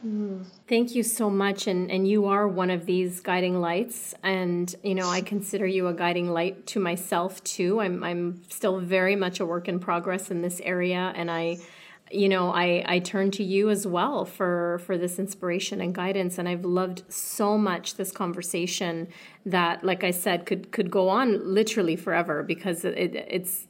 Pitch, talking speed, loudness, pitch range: 185 Hz, 185 wpm, -26 LUFS, 175-195 Hz